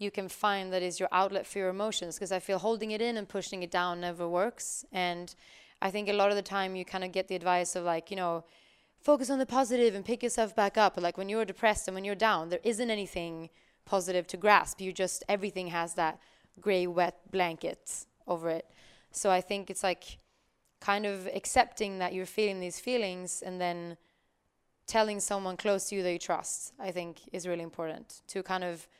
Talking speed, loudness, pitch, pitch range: 215 wpm, -32 LUFS, 190 Hz, 180-205 Hz